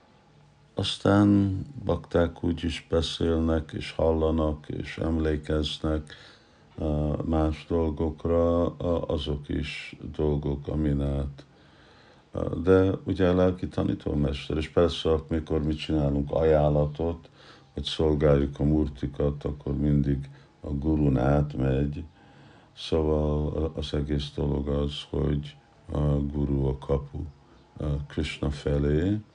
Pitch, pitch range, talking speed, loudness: 75 Hz, 70-80 Hz, 100 wpm, -27 LUFS